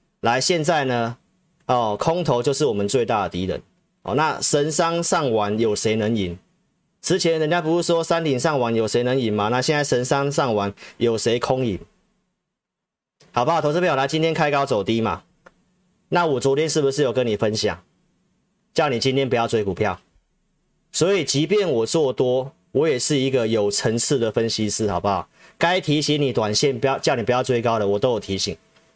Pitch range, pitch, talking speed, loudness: 115-160 Hz, 135 Hz, 270 characters per minute, -21 LUFS